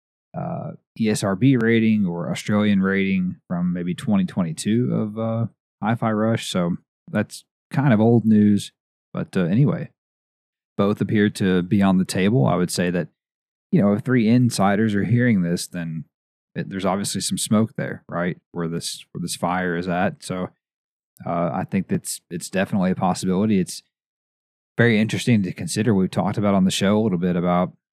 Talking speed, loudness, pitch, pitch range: 170 wpm, -21 LUFS, 105 Hz, 90-115 Hz